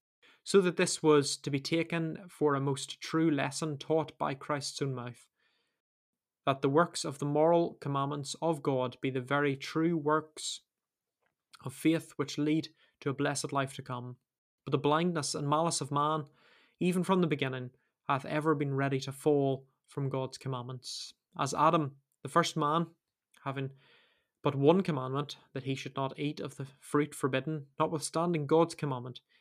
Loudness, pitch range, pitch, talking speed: -32 LUFS, 135-160 Hz, 145 Hz, 165 wpm